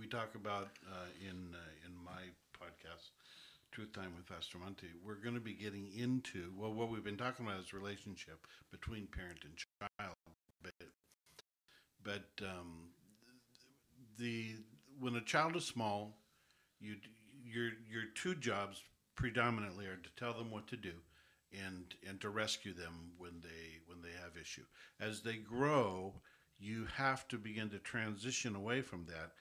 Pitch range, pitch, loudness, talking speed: 90-115 Hz, 105 Hz, -44 LUFS, 155 wpm